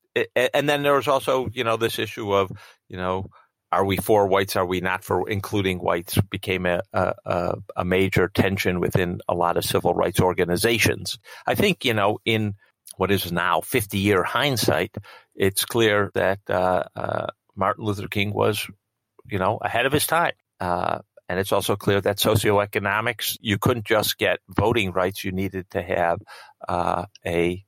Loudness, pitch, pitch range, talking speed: -23 LUFS, 100 Hz, 95-110 Hz, 170 wpm